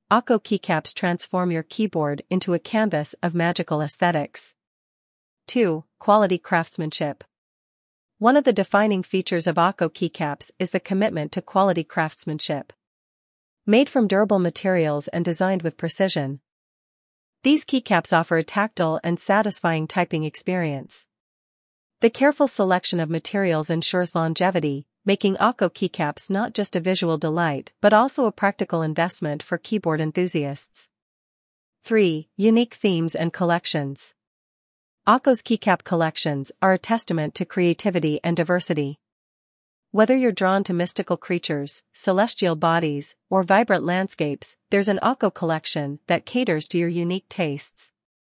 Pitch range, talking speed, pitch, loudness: 160-200 Hz, 130 wpm, 175 Hz, -22 LUFS